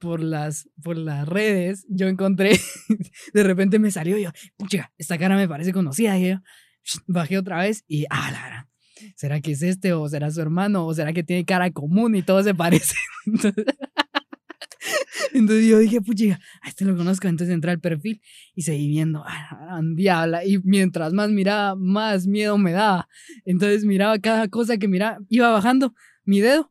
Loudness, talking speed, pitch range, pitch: -21 LUFS, 185 wpm, 170-215 Hz, 195 Hz